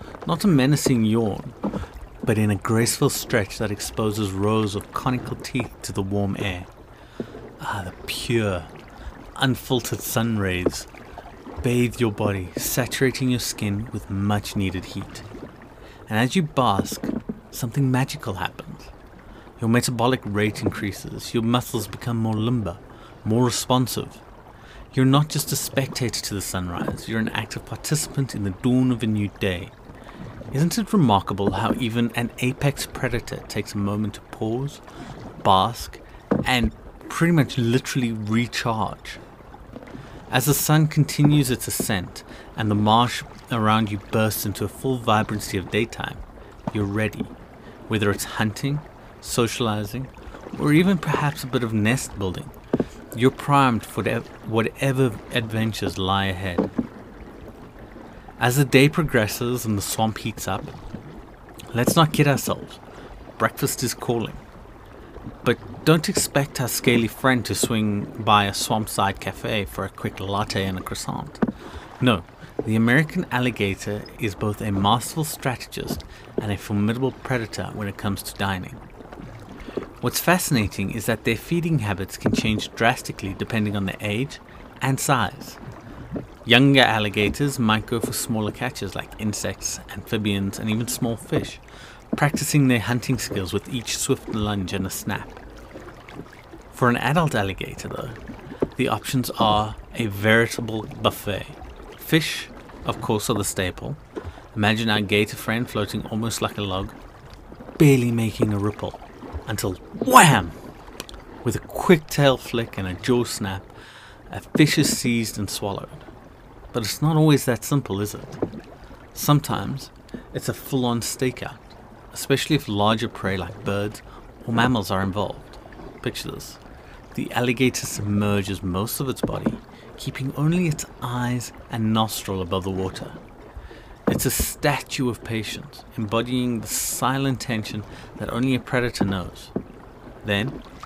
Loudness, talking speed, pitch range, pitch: -23 LUFS, 140 wpm, 105-130 Hz, 115 Hz